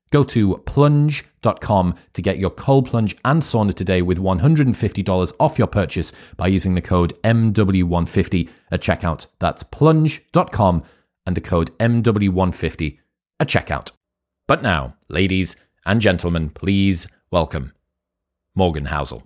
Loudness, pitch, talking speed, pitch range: -19 LUFS, 95 Hz, 125 wpm, 85-110 Hz